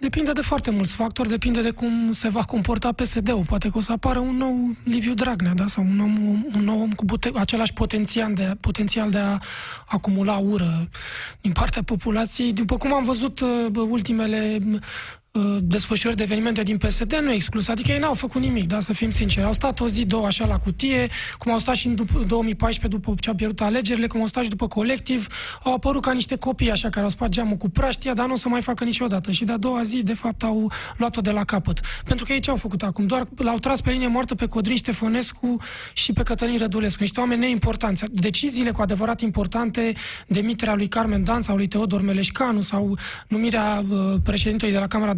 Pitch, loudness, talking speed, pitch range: 225 Hz, -23 LUFS, 215 wpm, 210-240 Hz